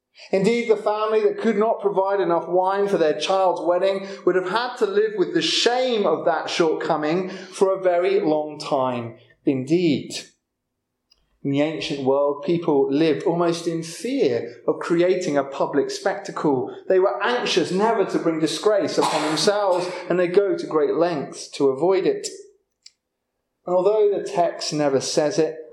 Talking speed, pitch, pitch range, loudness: 160 wpm, 185 Hz, 155-215 Hz, -21 LUFS